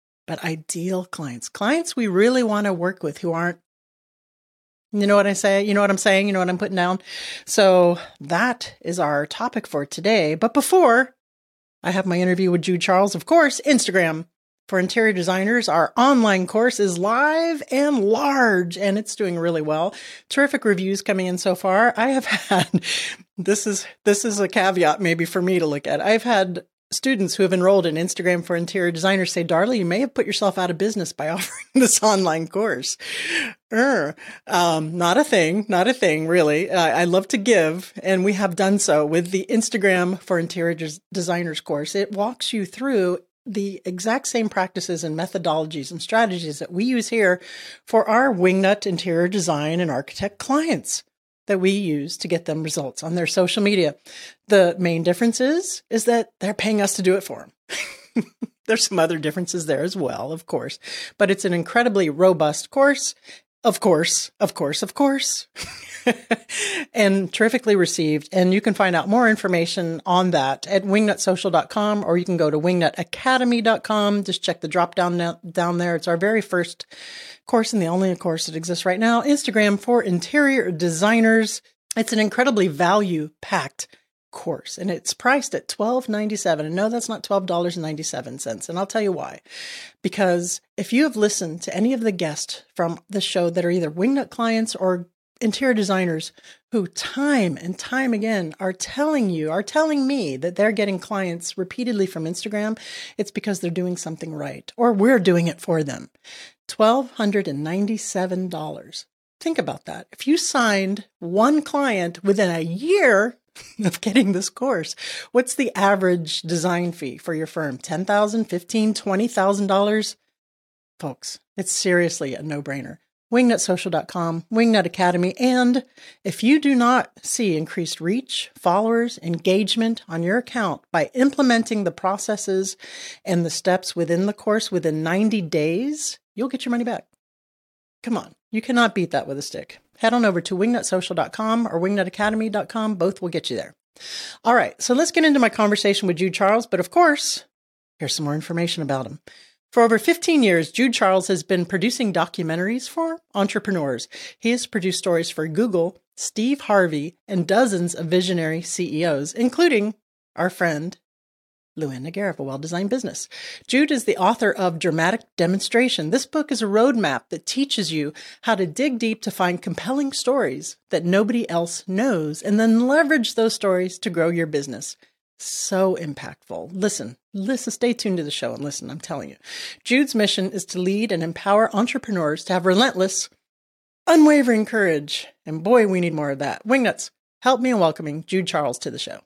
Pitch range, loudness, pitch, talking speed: 175-230 Hz, -21 LUFS, 195 Hz, 175 wpm